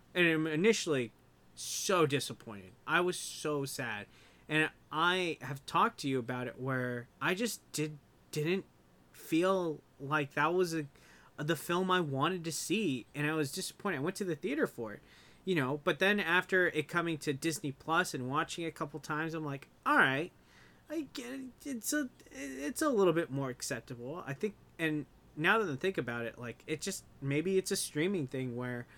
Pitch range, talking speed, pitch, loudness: 135-185 Hz, 195 wpm, 155 Hz, -34 LUFS